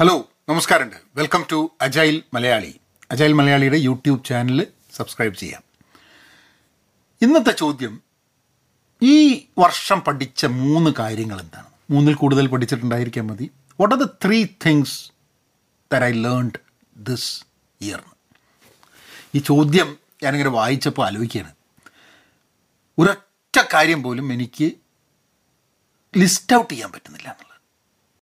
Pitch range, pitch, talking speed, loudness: 125-160 Hz, 145 Hz, 100 wpm, -18 LUFS